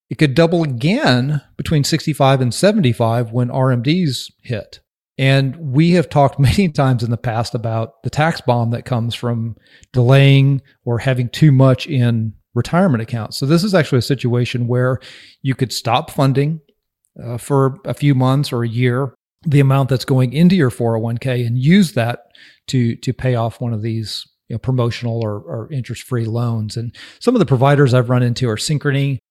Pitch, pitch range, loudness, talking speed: 130 Hz, 120-140 Hz, -16 LUFS, 180 wpm